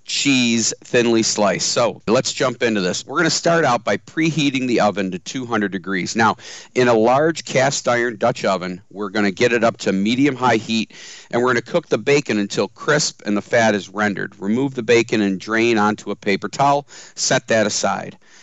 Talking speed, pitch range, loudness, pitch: 210 wpm, 105-135 Hz, -18 LUFS, 115 Hz